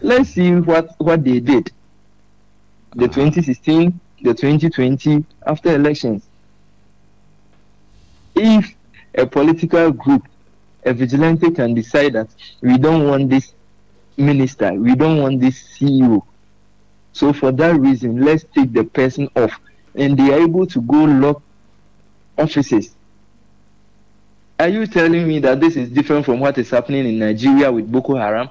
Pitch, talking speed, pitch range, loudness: 130 Hz, 135 wpm, 105-150 Hz, -15 LUFS